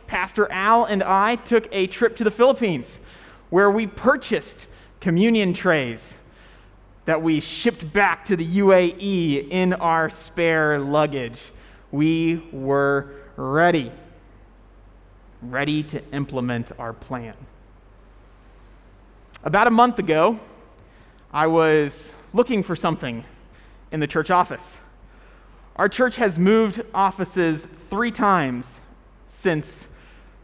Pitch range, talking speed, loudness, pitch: 135-200 Hz, 110 wpm, -21 LUFS, 165 Hz